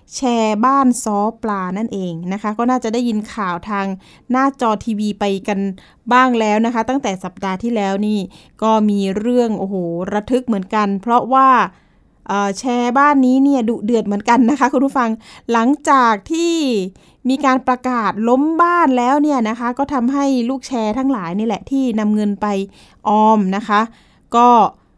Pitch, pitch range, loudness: 225 Hz, 205-255 Hz, -16 LUFS